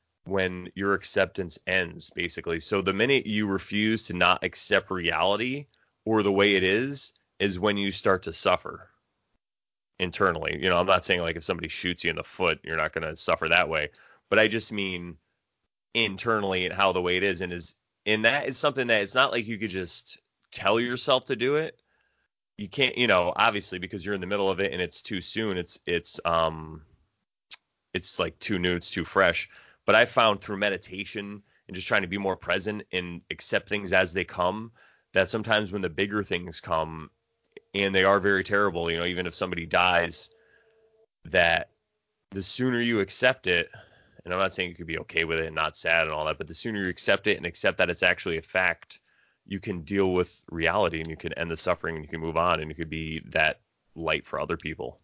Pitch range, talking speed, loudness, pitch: 85-110 Hz, 215 wpm, -26 LUFS, 95 Hz